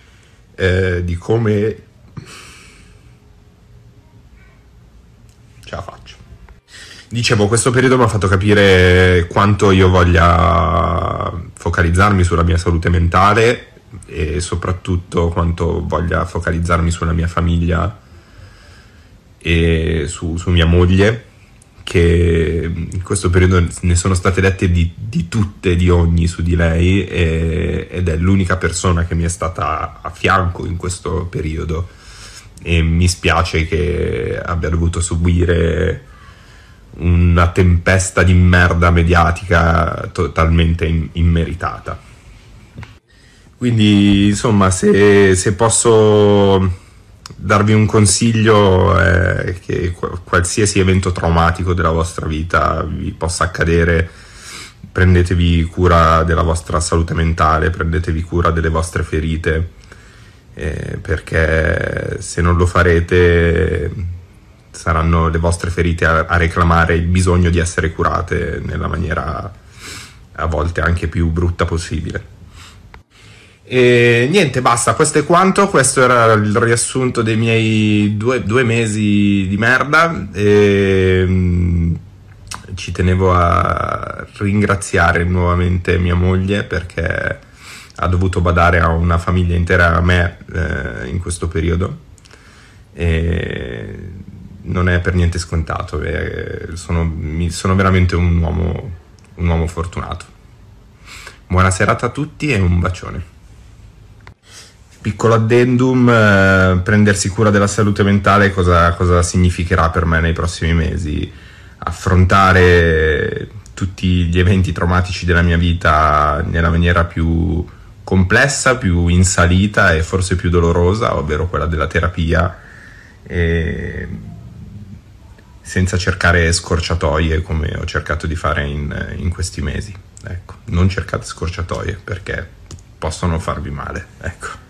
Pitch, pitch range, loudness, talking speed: 90 Hz, 85-100 Hz, -14 LUFS, 115 wpm